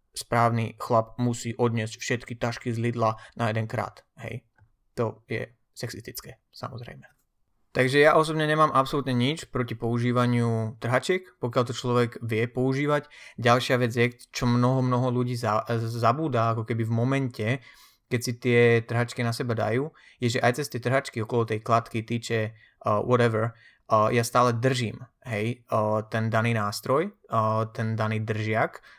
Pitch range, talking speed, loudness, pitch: 115-125 Hz, 155 wpm, -26 LUFS, 120 Hz